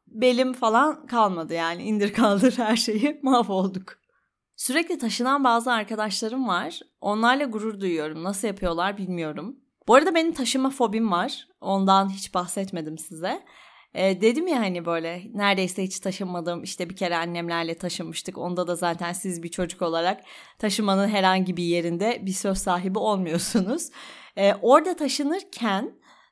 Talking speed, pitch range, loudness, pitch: 140 wpm, 180-245 Hz, -24 LUFS, 200 Hz